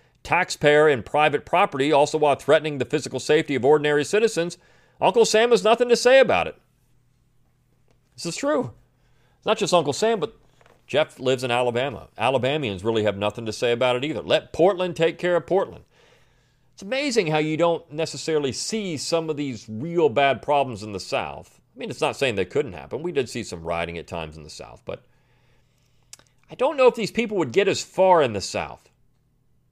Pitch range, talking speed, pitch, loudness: 125-175 Hz, 195 wpm, 145 Hz, -22 LUFS